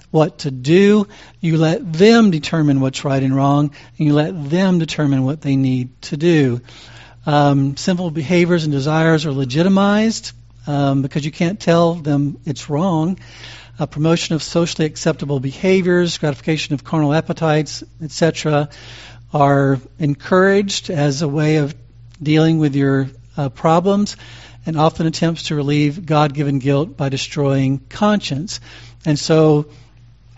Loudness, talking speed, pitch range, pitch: -17 LUFS, 140 wpm, 135-165 Hz, 150 Hz